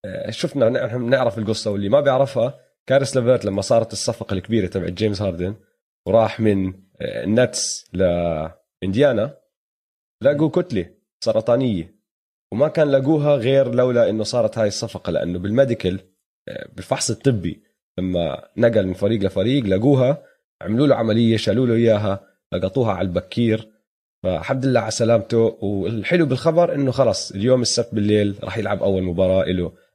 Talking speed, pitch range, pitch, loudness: 135 wpm, 95-125 Hz, 110 Hz, -20 LUFS